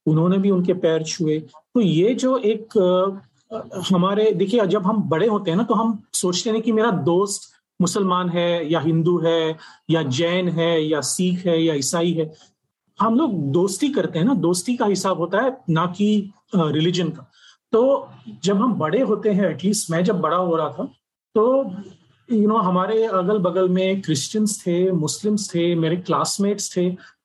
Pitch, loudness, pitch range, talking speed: 185 Hz, -20 LUFS, 165-210 Hz, 180 wpm